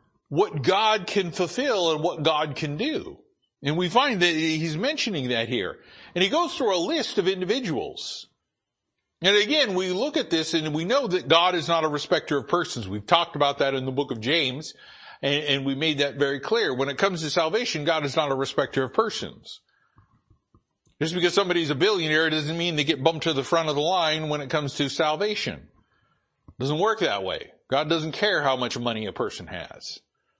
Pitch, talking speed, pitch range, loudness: 160 Hz, 205 wpm, 145-180 Hz, -24 LUFS